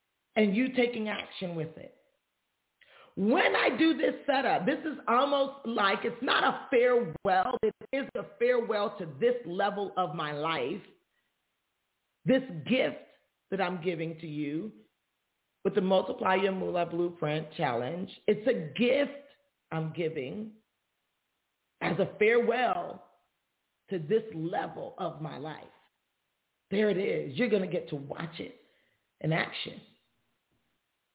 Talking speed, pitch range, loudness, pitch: 130 wpm, 170-250 Hz, -30 LUFS, 205 Hz